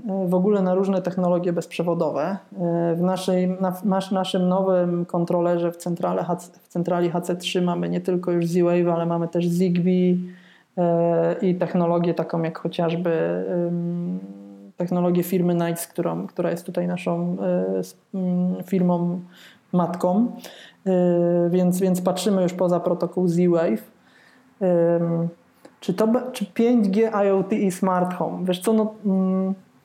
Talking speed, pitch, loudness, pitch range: 135 wpm, 180 Hz, -22 LUFS, 170-185 Hz